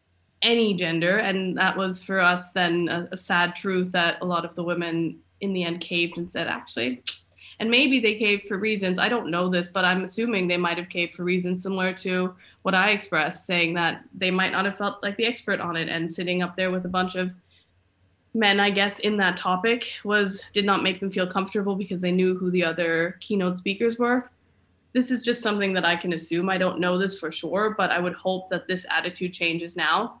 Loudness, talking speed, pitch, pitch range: -24 LUFS, 225 wpm, 185 Hz, 175-200 Hz